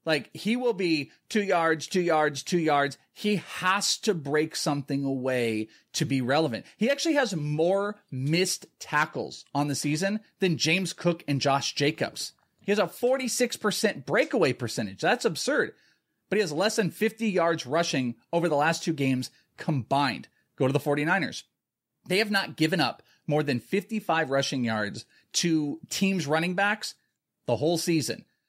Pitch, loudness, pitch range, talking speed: 165 Hz, -27 LUFS, 145-195 Hz, 160 wpm